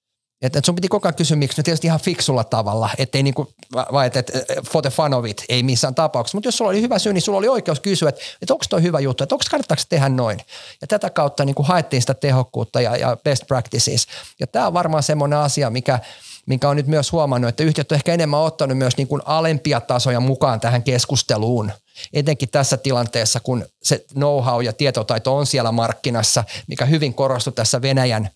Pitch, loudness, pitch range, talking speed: 140 Hz, -19 LUFS, 125-155 Hz, 205 wpm